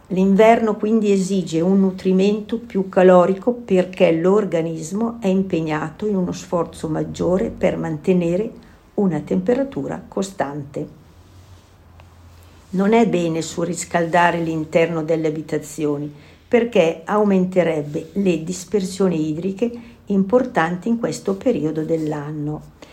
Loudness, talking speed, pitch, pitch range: -19 LUFS, 95 wpm, 180 Hz, 155-200 Hz